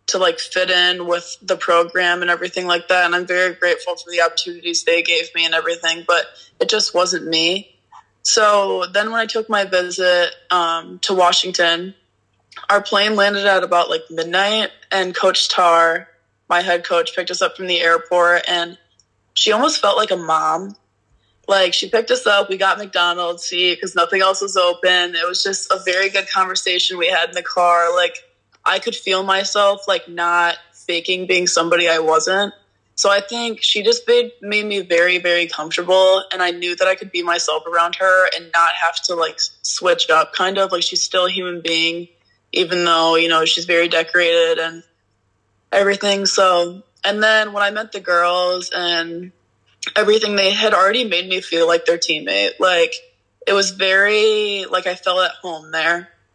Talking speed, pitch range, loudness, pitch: 185 wpm, 170-195 Hz, -16 LUFS, 180 Hz